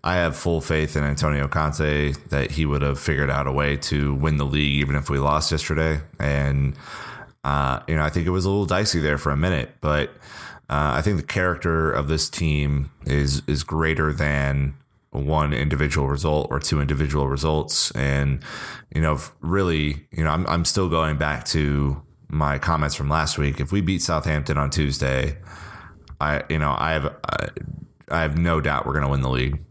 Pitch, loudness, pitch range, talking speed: 75 Hz, -22 LUFS, 70-80 Hz, 195 wpm